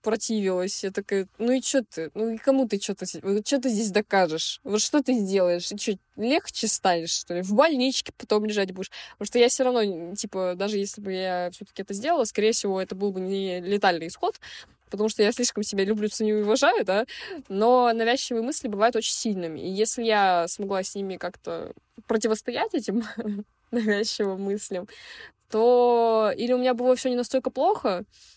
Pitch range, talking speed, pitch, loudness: 195-240 Hz, 185 wpm, 215 Hz, -25 LUFS